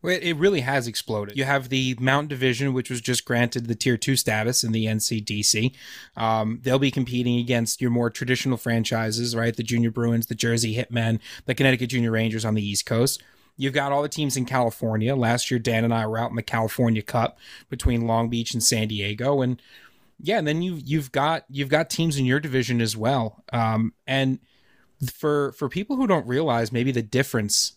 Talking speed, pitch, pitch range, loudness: 205 wpm, 125 Hz, 115-135 Hz, -24 LUFS